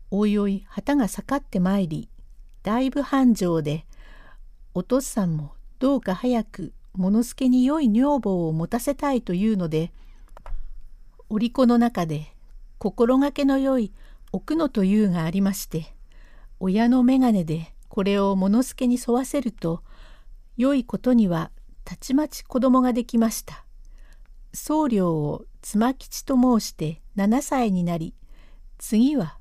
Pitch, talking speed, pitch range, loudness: 220 Hz, 255 characters per minute, 185-255 Hz, -23 LUFS